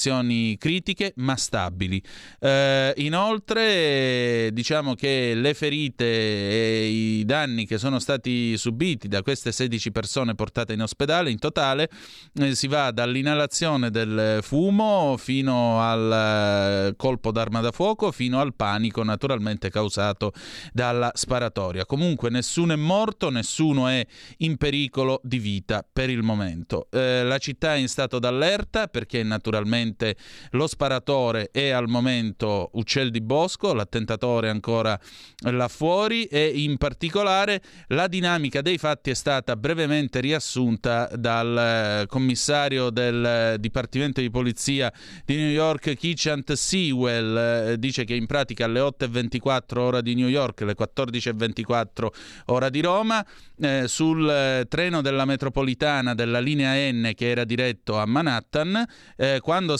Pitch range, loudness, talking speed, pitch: 115-145 Hz, -24 LUFS, 130 wpm, 125 Hz